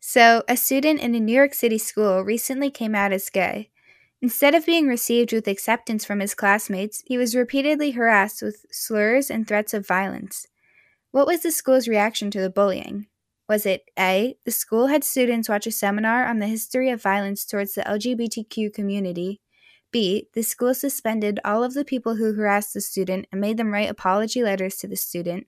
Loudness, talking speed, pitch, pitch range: -22 LUFS, 190 wpm, 220 Hz, 200-250 Hz